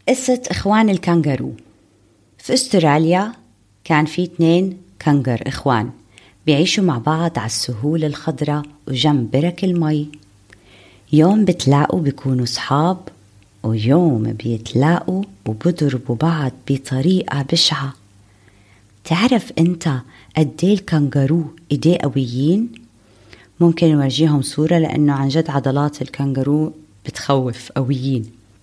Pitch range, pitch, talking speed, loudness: 120-165 Hz, 145 Hz, 95 wpm, -18 LUFS